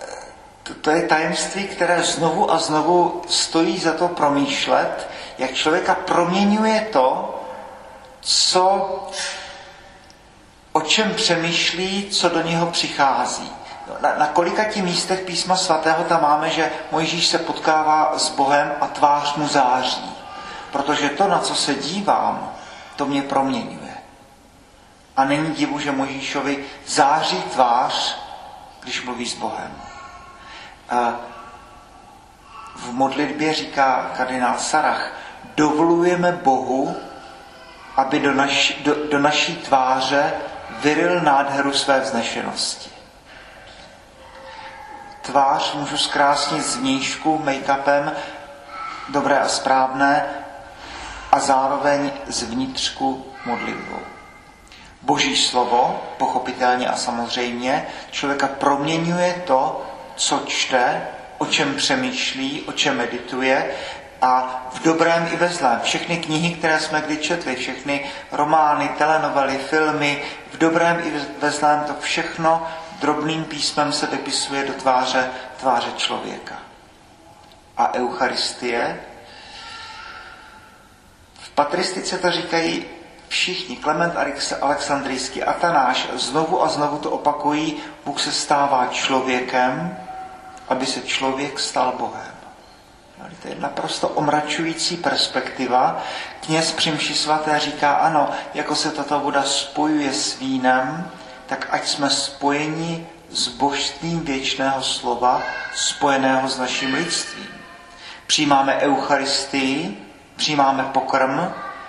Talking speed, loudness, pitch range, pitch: 105 wpm, -20 LUFS, 135-170 Hz, 150 Hz